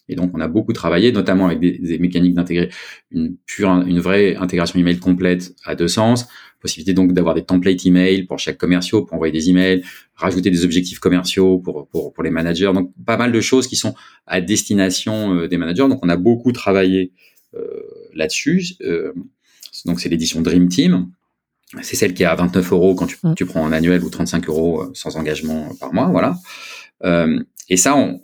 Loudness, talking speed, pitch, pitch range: -17 LUFS, 200 wpm, 90 Hz, 85-100 Hz